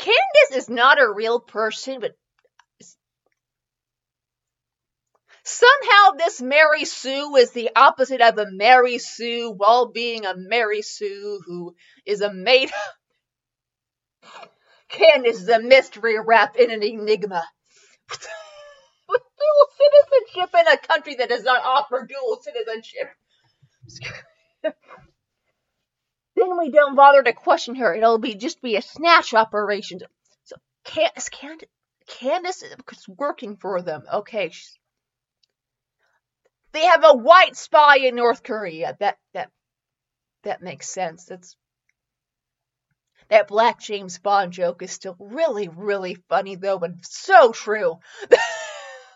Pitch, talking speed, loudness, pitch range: 245 Hz, 115 wpm, -18 LUFS, 210-305 Hz